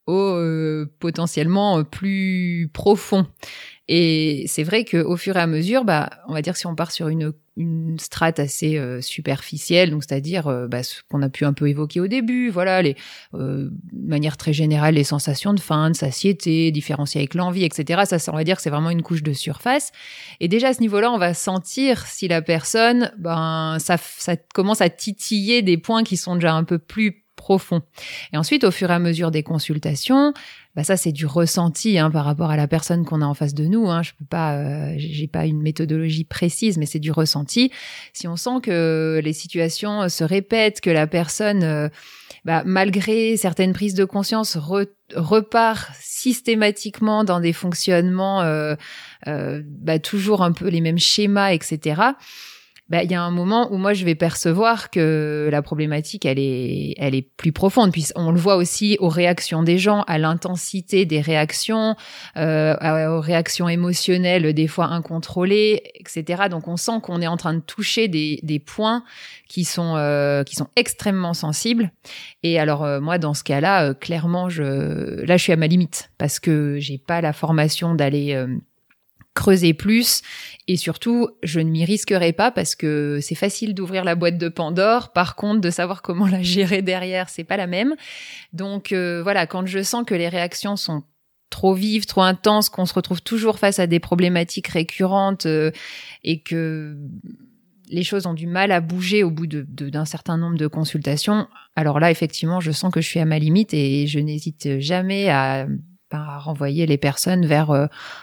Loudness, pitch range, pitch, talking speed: -20 LUFS, 155-195 Hz, 170 Hz, 195 wpm